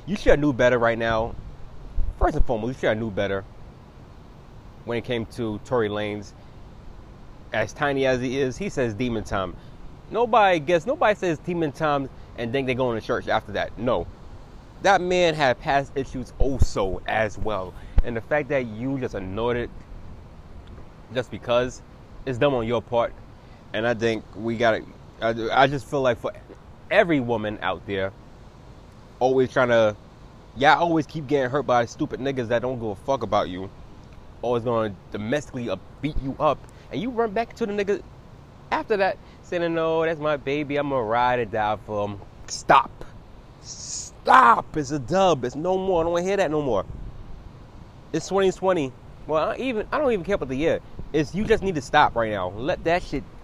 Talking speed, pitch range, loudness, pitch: 185 wpm, 110-150 Hz, -24 LUFS, 125 Hz